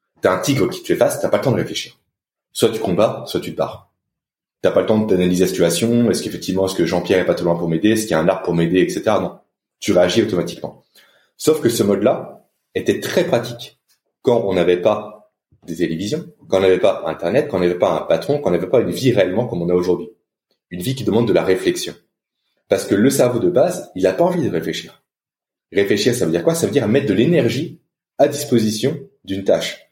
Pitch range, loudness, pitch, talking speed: 90-130 Hz, -18 LUFS, 95 Hz, 240 wpm